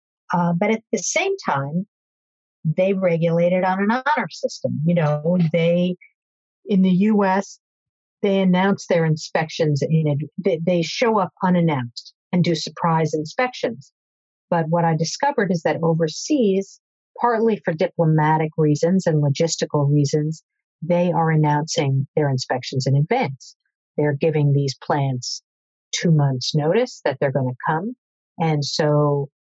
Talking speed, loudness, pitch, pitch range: 140 wpm, -20 LUFS, 165 Hz, 150-190 Hz